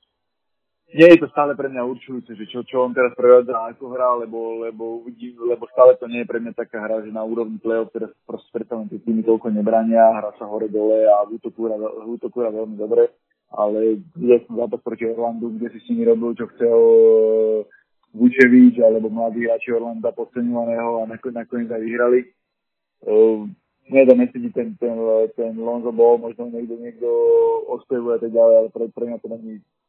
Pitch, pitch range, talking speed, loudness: 115 Hz, 115-125 Hz, 185 wpm, -18 LUFS